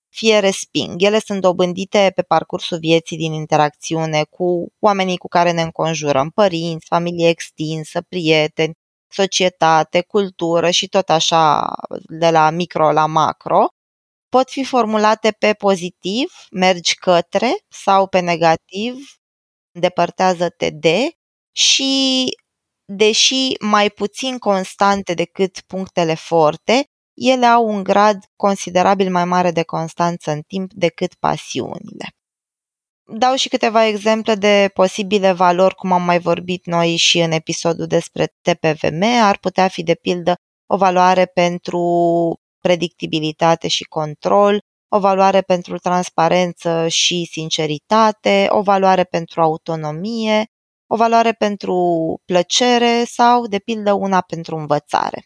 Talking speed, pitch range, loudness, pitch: 120 wpm, 170-205 Hz, -16 LUFS, 180 Hz